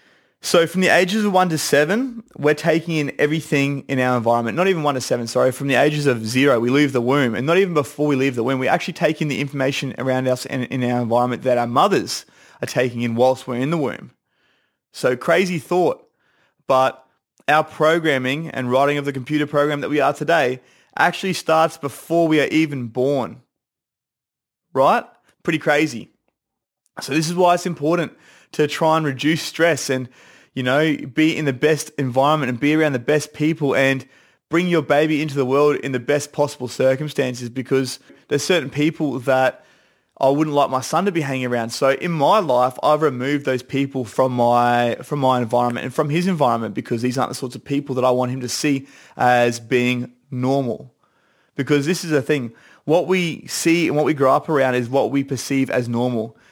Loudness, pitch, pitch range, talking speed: -19 LUFS, 140 Hz, 130-155 Hz, 205 wpm